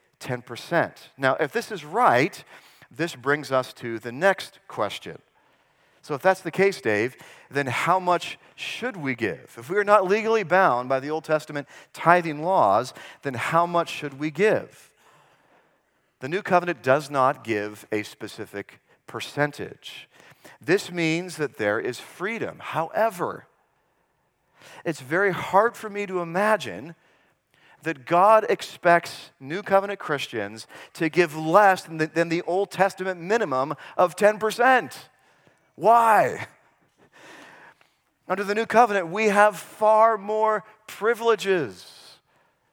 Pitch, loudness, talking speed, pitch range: 175 Hz, -23 LUFS, 130 wpm, 145-200 Hz